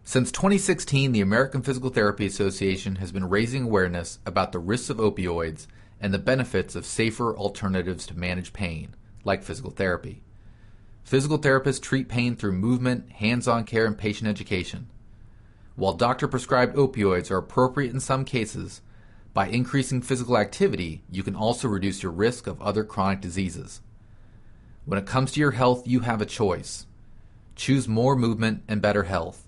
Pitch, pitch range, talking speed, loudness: 110 Hz, 100-125 Hz, 160 wpm, -25 LUFS